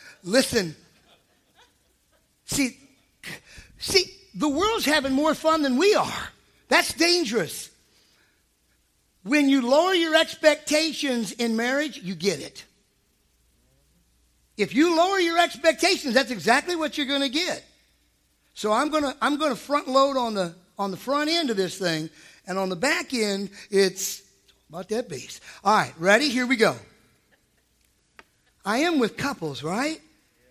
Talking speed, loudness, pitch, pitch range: 140 wpm, -23 LUFS, 250 Hz, 185-300 Hz